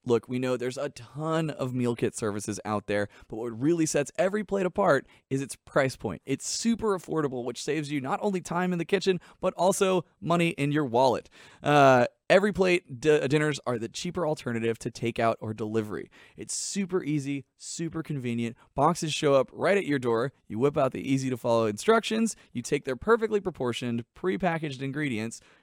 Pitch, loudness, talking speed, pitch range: 145 Hz, -28 LUFS, 185 wpm, 120-175 Hz